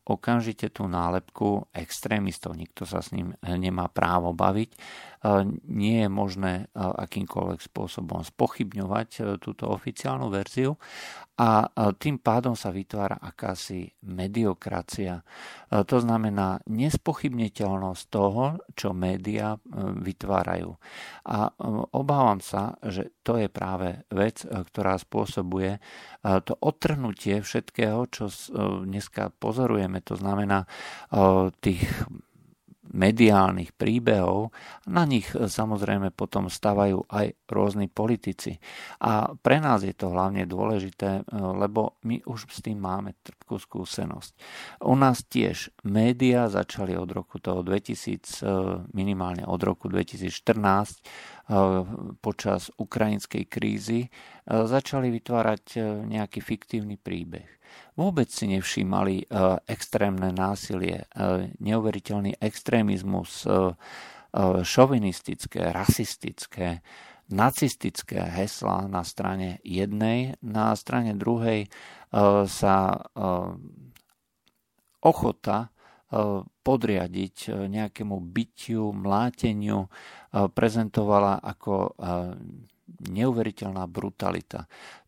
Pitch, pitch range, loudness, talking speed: 100 Hz, 95-110 Hz, -27 LUFS, 90 wpm